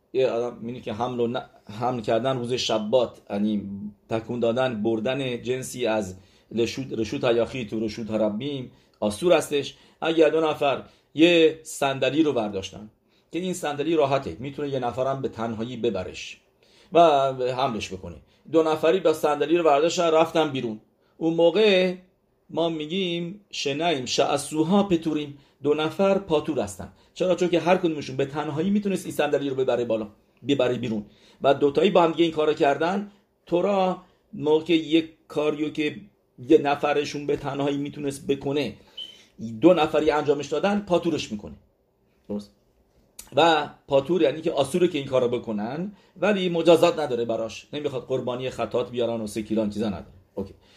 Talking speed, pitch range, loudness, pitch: 145 wpm, 115-160 Hz, -24 LUFS, 140 Hz